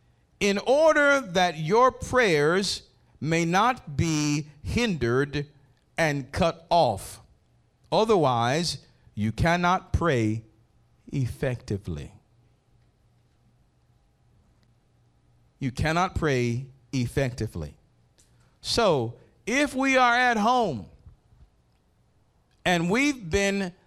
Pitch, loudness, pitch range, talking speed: 145 Hz, -25 LUFS, 120-190 Hz, 75 wpm